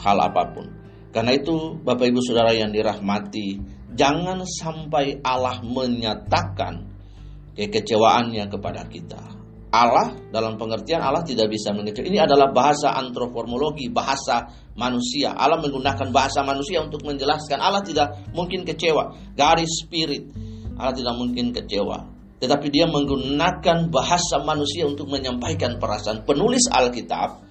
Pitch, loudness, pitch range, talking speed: 130 Hz, -22 LUFS, 110-150 Hz, 120 wpm